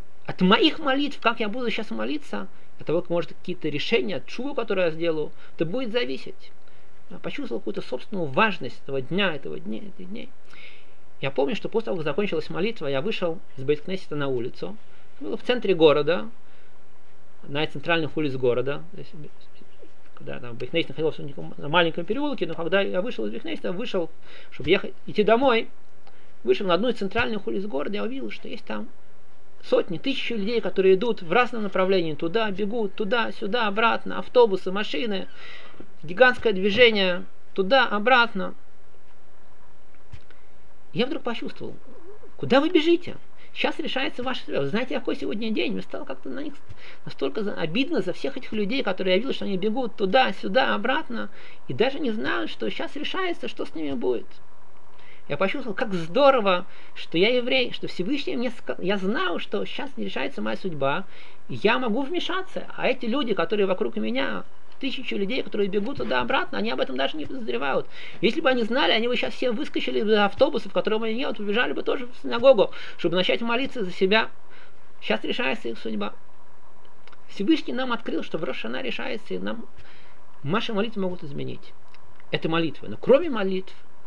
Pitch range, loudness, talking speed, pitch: 185-260 Hz, -25 LUFS, 170 wpm, 220 Hz